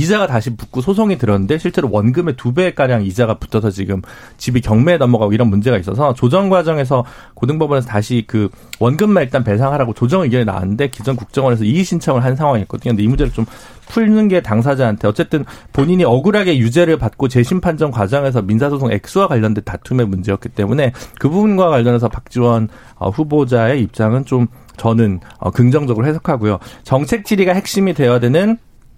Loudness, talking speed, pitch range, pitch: -15 LUFS, 425 characters per minute, 115-150 Hz, 125 Hz